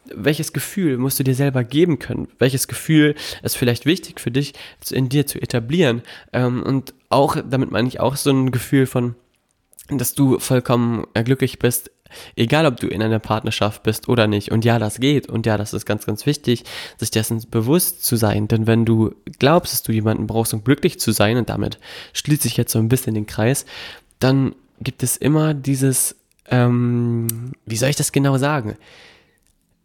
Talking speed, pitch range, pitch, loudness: 185 wpm, 115-140 Hz, 125 Hz, -19 LUFS